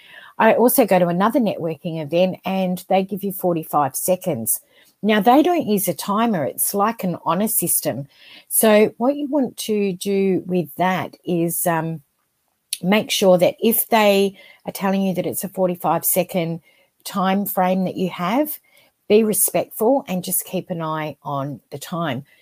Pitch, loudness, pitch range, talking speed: 185 Hz, -19 LUFS, 175-210 Hz, 165 wpm